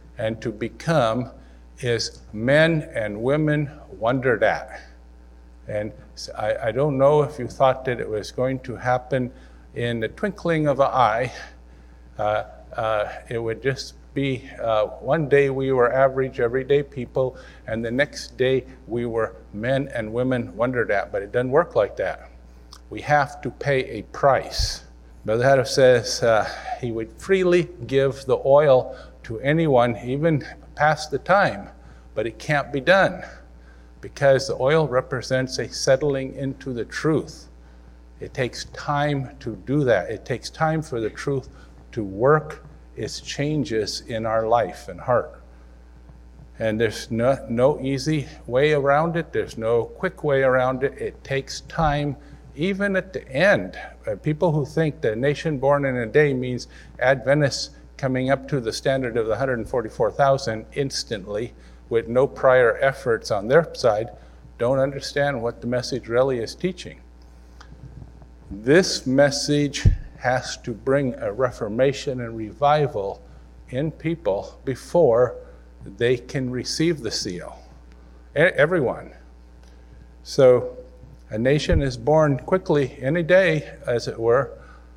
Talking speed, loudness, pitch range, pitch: 145 wpm, -22 LUFS, 105-145 Hz, 130 Hz